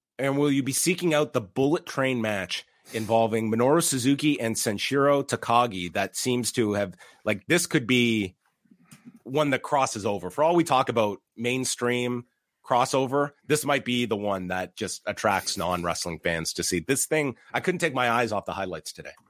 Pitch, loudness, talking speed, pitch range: 125 Hz, -25 LUFS, 185 wpm, 115-140 Hz